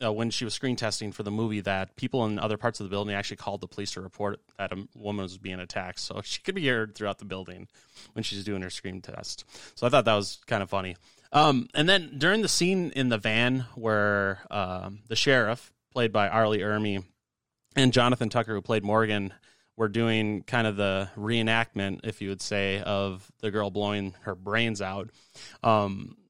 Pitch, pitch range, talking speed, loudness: 105 Hz, 100-115 Hz, 210 wpm, -28 LUFS